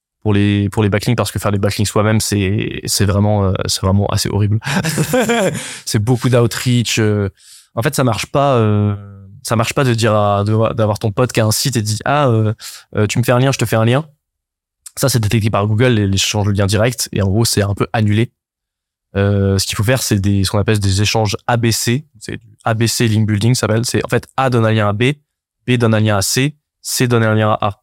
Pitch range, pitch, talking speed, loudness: 105-125 Hz, 110 Hz, 250 wpm, -15 LUFS